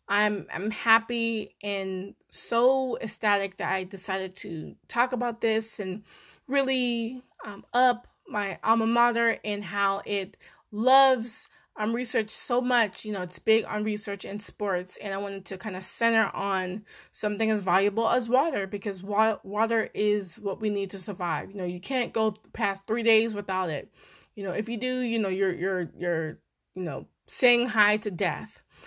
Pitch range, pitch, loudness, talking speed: 195-230 Hz, 210 Hz, -27 LUFS, 175 wpm